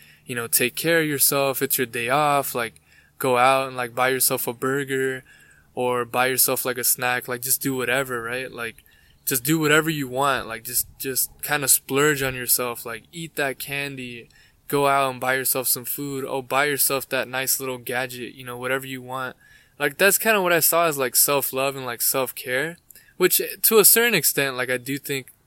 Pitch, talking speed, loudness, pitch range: 130 Hz, 210 wpm, -21 LUFS, 125-140 Hz